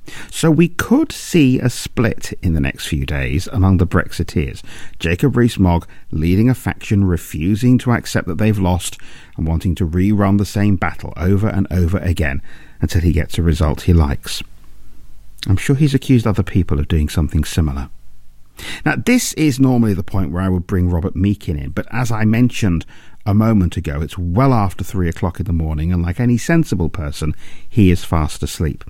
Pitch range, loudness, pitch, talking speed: 85-110 Hz, -17 LUFS, 95 Hz, 190 wpm